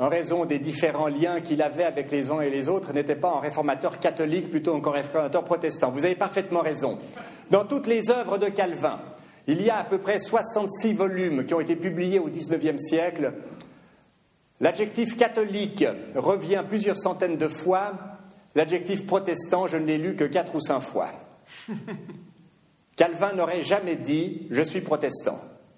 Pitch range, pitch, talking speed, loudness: 155-195 Hz, 175 Hz, 170 wpm, -26 LUFS